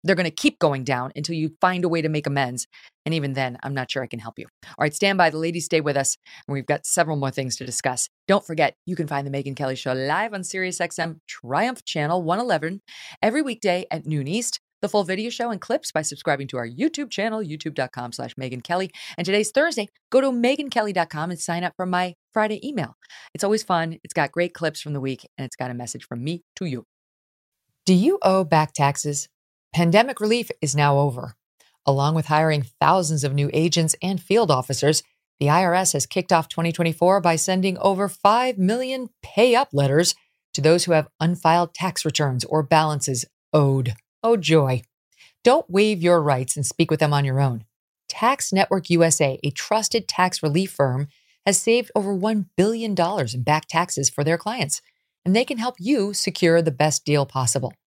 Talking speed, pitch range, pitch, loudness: 205 wpm, 140-195 Hz, 165 Hz, -22 LUFS